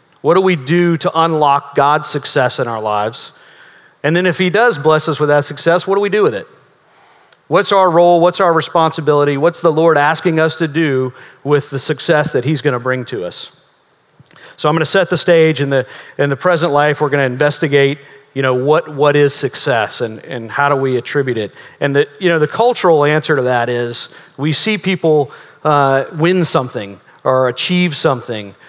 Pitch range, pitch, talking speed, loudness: 135-165 Hz, 150 Hz, 205 wpm, -14 LUFS